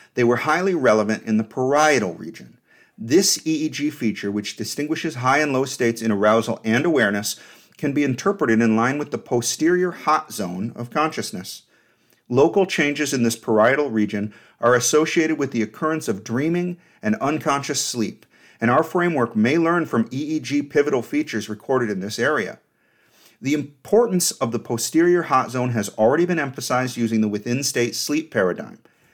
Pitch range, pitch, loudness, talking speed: 115-155 Hz, 130 Hz, -21 LUFS, 165 wpm